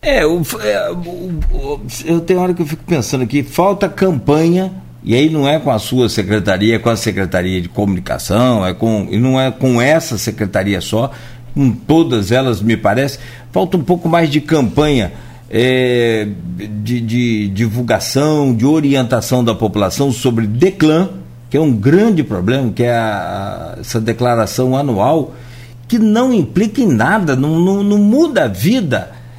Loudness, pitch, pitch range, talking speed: -14 LUFS, 125 Hz, 115-160 Hz, 165 wpm